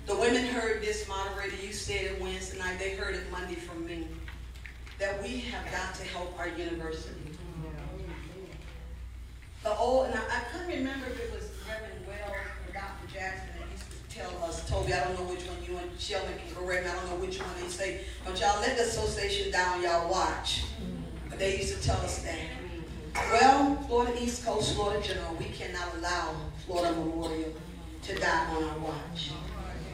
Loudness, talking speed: -32 LUFS, 185 wpm